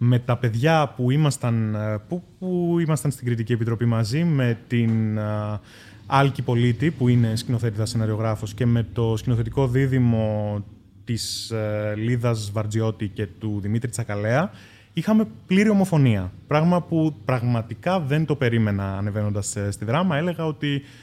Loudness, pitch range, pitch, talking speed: -23 LUFS, 110-140 Hz, 120 Hz, 125 wpm